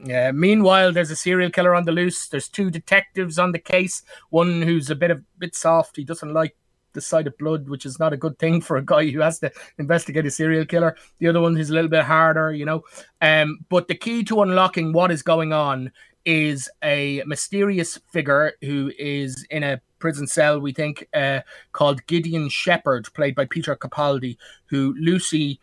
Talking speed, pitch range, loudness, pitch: 205 wpm, 145-170 Hz, -21 LUFS, 160 Hz